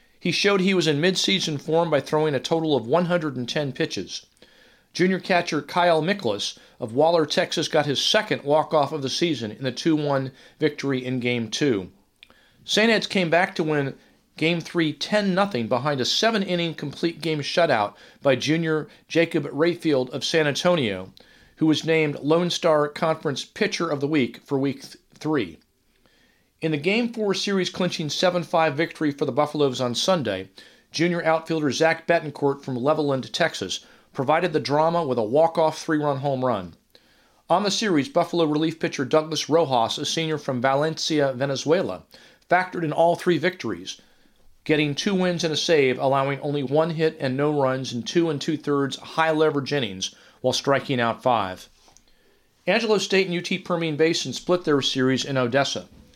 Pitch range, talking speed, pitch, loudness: 140-170 Hz, 165 wpm, 155 Hz, -23 LUFS